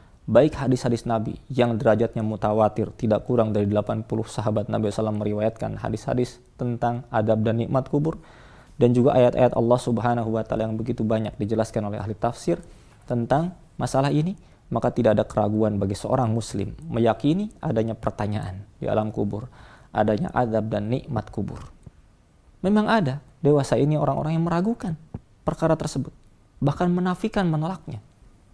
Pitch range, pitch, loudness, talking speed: 110-140 Hz, 120 Hz, -24 LUFS, 140 wpm